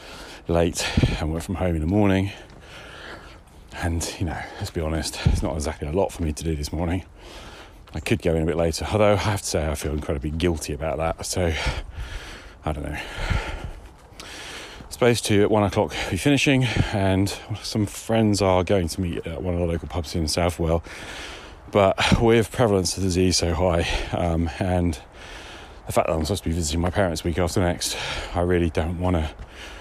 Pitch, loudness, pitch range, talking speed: 90 Hz, -23 LUFS, 80-100 Hz, 195 wpm